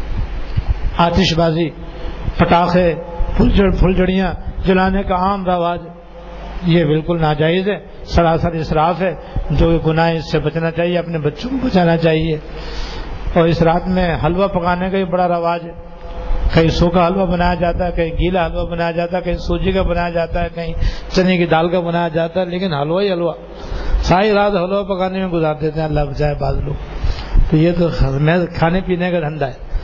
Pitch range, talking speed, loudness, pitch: 160-180 Hz, 180 wpm, -17 LUFS, 170 Hz